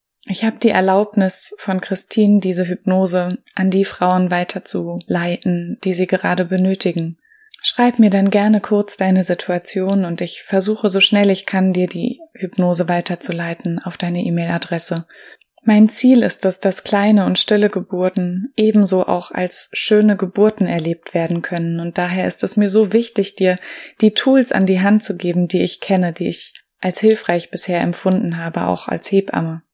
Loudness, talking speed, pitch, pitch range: -16 LUFS, 165 wpm, 190 Hz, 175-210 Hz